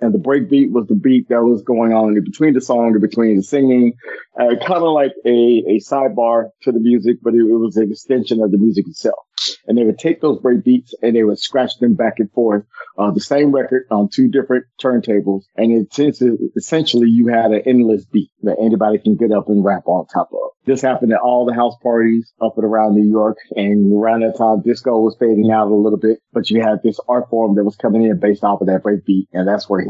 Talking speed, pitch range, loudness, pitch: 250 wpm, 110-125 Hz, -15 LUFS, 115 Hz